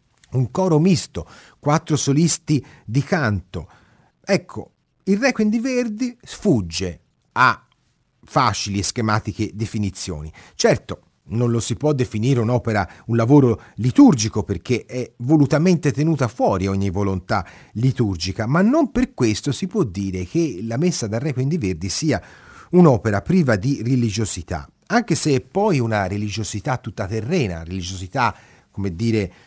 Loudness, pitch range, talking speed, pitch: -20 LUFS, 100-155 Hz, 135 wpm, 120 Hz